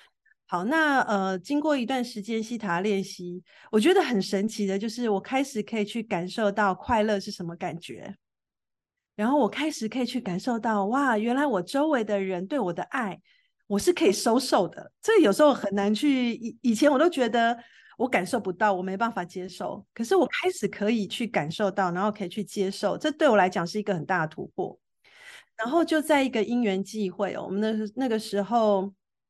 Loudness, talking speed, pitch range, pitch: -26 LUFS, 285 characters per minute, 200-260 Hz, 215 Hz